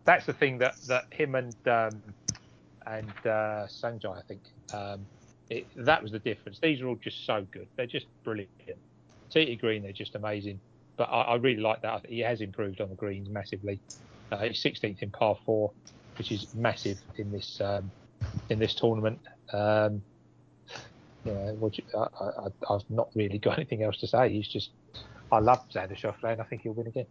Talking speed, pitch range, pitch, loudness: 195 wpm, 105-120 Hz, 110 Hz, -31 LUFS